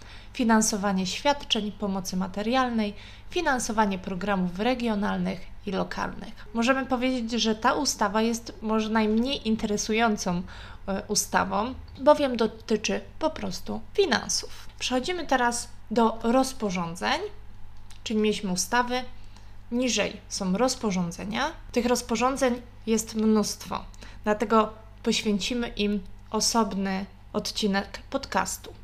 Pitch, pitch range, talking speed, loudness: 220 Hz, 200-245 Hz, 90 wpm, -27 LUFS